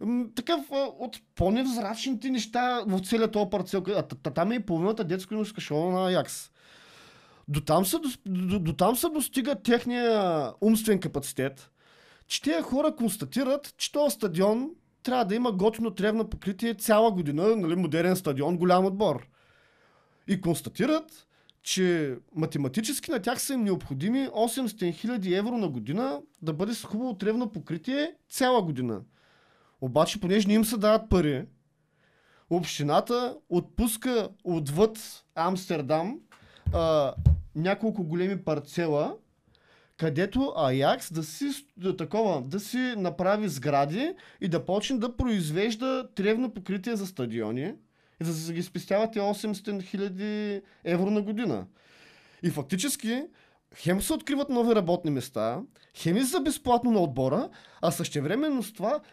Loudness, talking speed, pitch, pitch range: -28 LUFS, 130 wpm, 200 Hz, 165-240 Hz